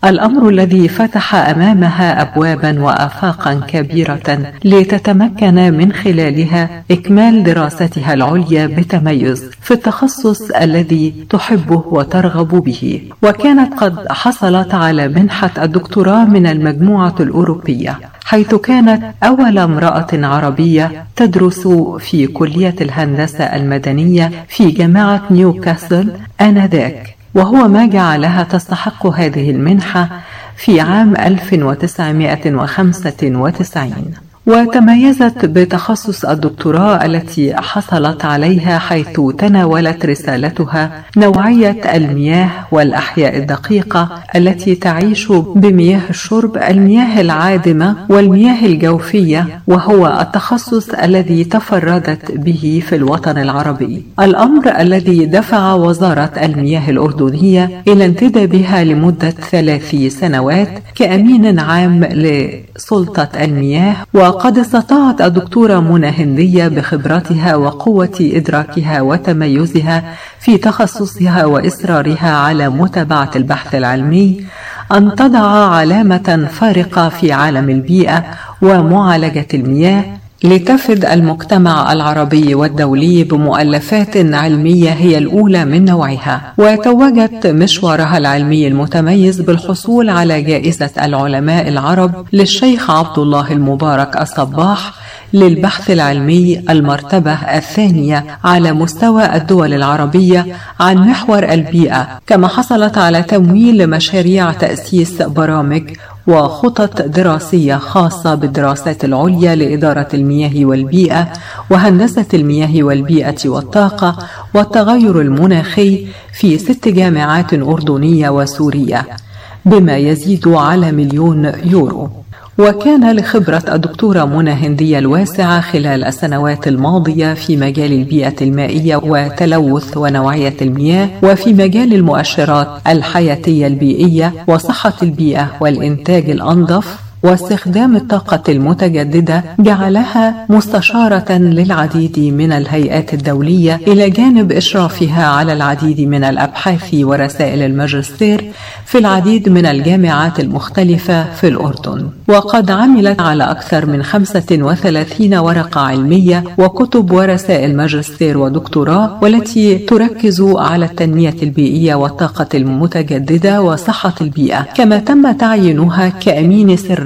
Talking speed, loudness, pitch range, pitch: 95 wpm, -10 LUFS, 150-195 Hz, 170 Hz